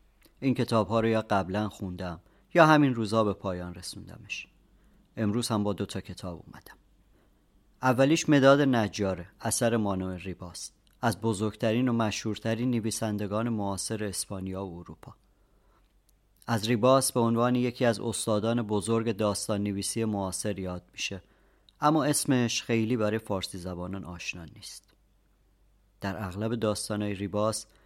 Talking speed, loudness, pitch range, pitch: 125 wpm, -28 LUFS, 100-115 Hz, 105 Hz